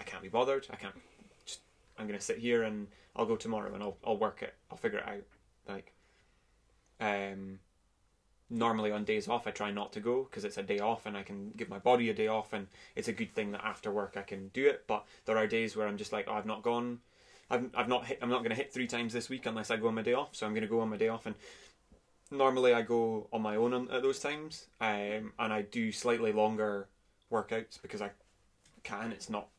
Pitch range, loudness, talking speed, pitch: 105-120 Hz, -35 LUFS, 245 wpm, 110 Hz